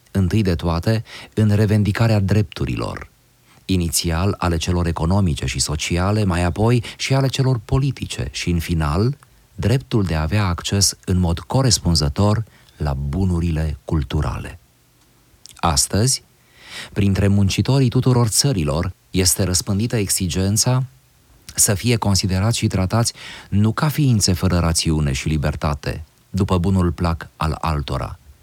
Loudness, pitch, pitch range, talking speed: -19 LUFS, 95 Hz, 85-110 Hz, 120 wpm